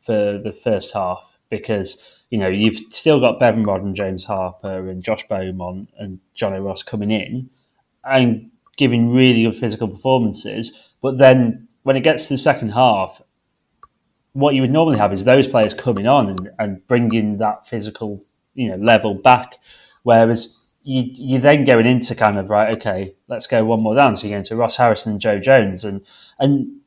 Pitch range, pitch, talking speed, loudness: 100-130 Hz, 115 Hz, 185 wpm, -17 LUFS